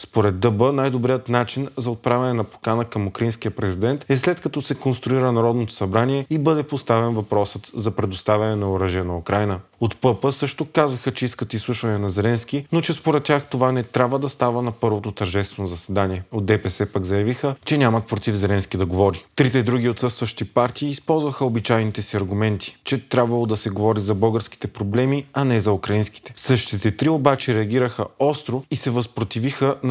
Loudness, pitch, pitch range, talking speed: -21 LUFS, 120 Hz, 105-135 Hz, 180 wpm